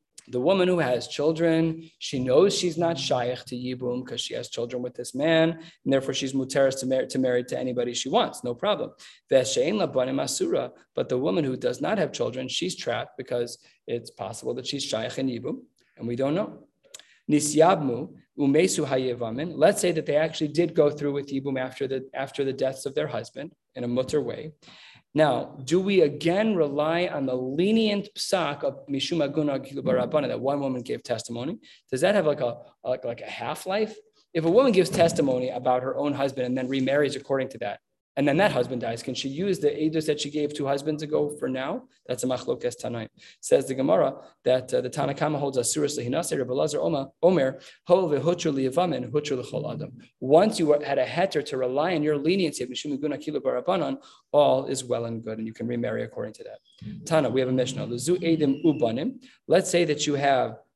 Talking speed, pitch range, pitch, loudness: 180 wpm, 130-170 Hz, 145 Hz, -26 LUFS